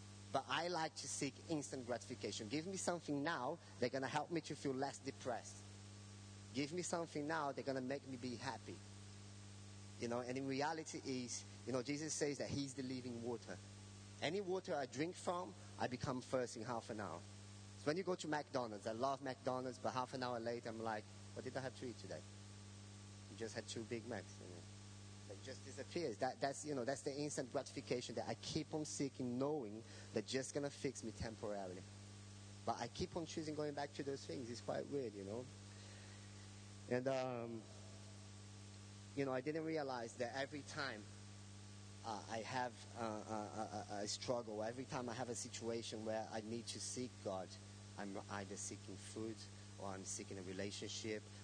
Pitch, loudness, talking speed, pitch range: 115 Hz, -46 LUFS, 190 wpm, 105-135 Hz